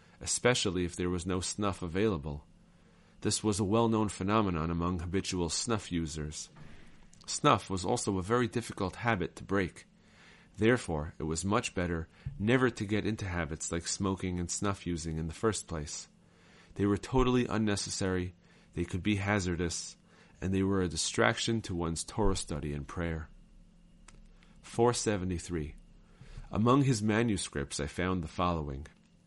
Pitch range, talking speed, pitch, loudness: 85-110 Hz, 150 wpm, 95 Hz, -32 LUFS